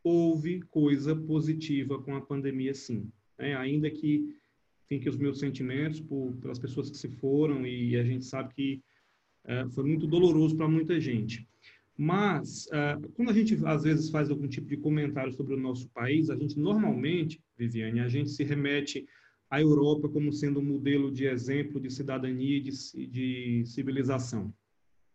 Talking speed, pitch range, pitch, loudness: 170 wpm, 130-150 Hz, 140 Hz, -30 LUFS